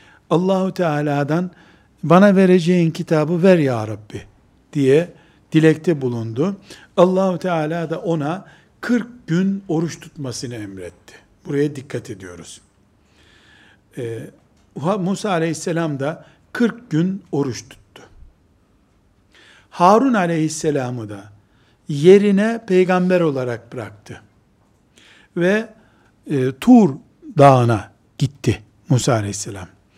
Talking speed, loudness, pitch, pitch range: 90 wpm, -18 LUFS, 155 Hz, 120-180 Hz